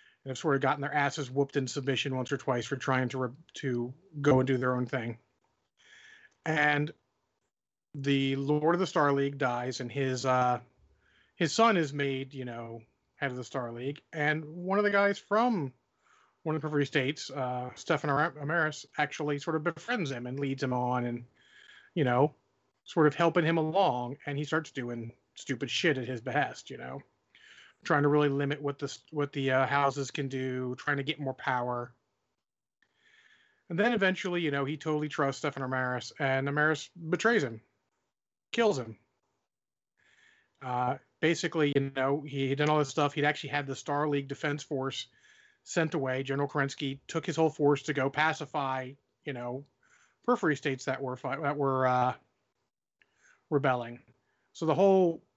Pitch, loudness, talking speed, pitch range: 140 Hz, -30 LUFS, 175 wpm, 130-155 Hz